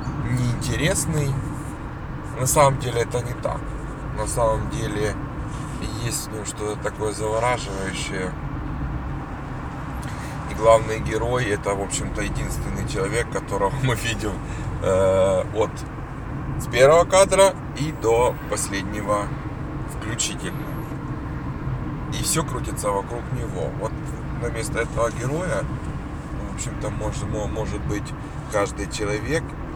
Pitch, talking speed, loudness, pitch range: 135 Hz, 105 wpm, -24 LUFS, 110-145 Hz